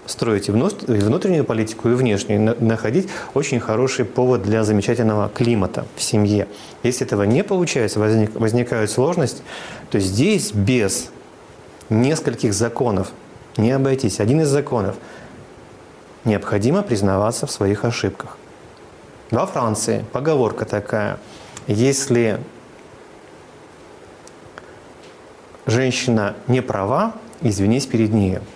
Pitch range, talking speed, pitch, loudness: 105-130 Hz, 100 wpm, 115 Hz, -19 LUFS